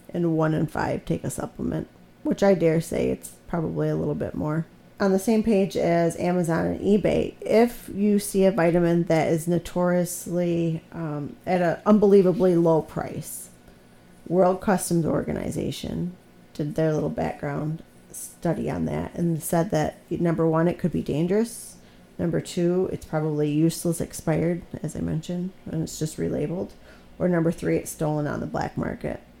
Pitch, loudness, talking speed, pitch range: 165 Hz, -24 LUFS, 165 wpm, 150-180 Hz